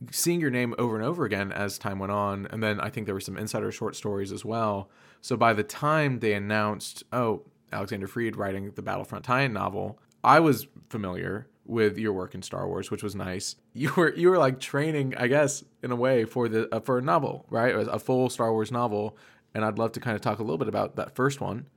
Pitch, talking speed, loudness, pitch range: 110 Hz, 245 wpm, -27 LUFS, 105-125 Hz